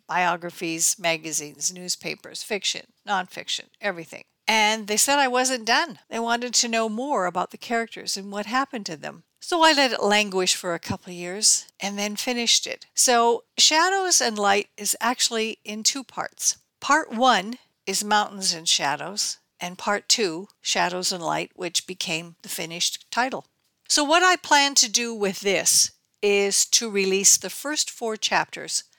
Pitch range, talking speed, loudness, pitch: 185-245 Hz, 165 wpm, -22 LUFS, 210 Hz